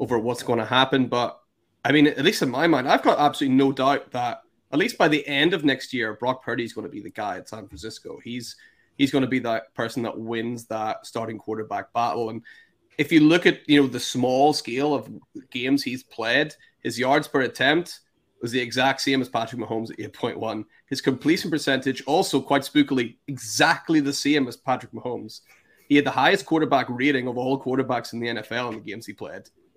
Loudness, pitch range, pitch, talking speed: -23 LUFS, 115-140 Hz, 125 Hz, 215 wpm